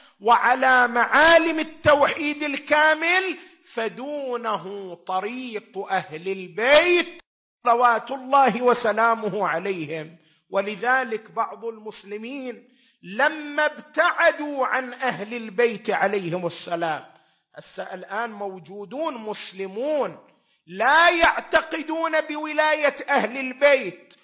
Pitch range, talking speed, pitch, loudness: 205-295 Hz, 75 wpm, 245 Hz, -22 LUFS